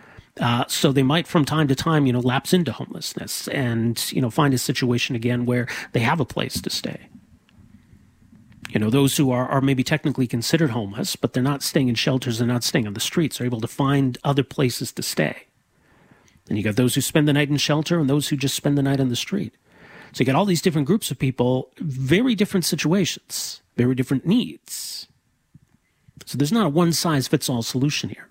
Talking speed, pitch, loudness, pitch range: 215 wpm, 135 Hz, -22 LUFS, 125-155 Hz